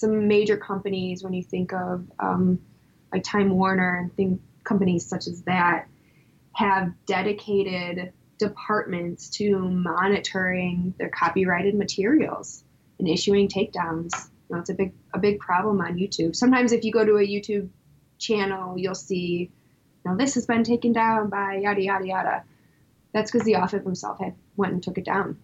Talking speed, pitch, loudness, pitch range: 155 wpm, 190 Hz, -24 LUFS, 180-205 Hz